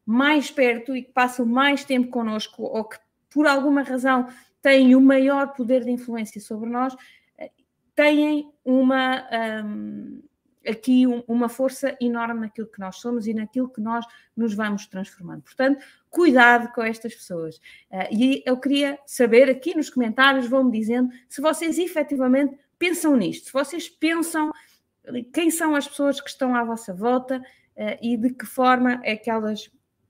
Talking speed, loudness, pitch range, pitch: 155 wpm, -22 LUFS, 230-275 Hz, 255 Hz